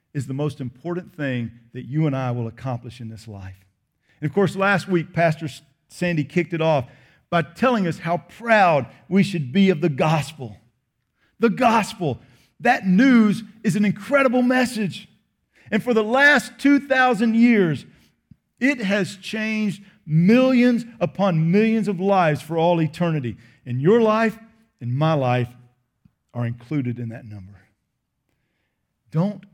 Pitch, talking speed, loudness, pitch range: 170 Hz, 145 wpm, -20 LUFS, 130-215 Hz